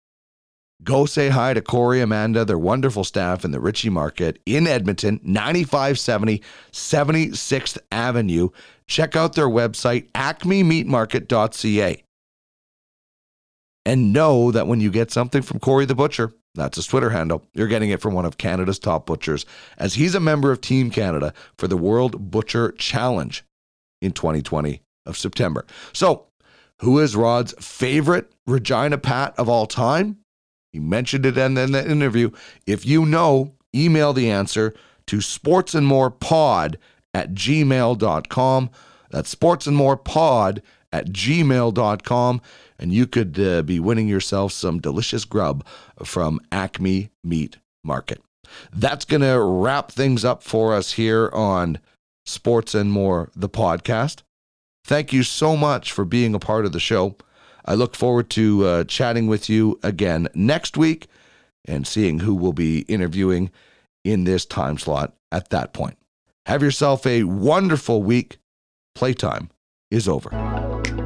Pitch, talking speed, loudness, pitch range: 115 Hz, 140 wpm, -20 LUFS, 95-135 Hz